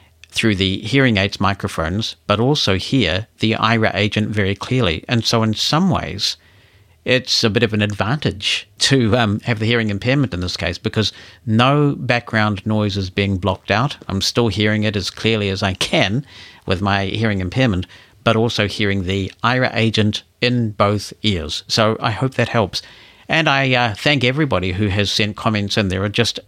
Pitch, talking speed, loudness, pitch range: 105 Hz, 185 wpm, -18 LUFS, 100-120 Hz